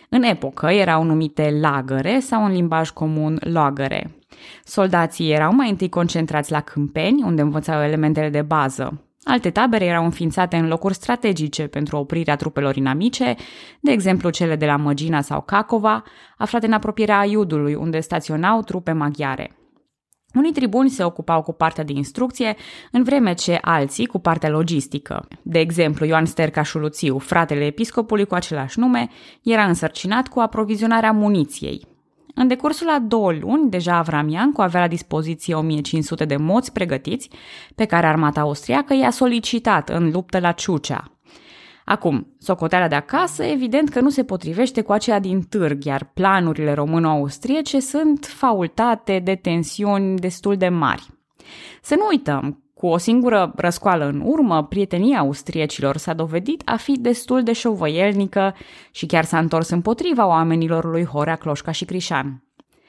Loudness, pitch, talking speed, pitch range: -19 LUFS, 175 Hz, 150 wpm, 155-225 Hz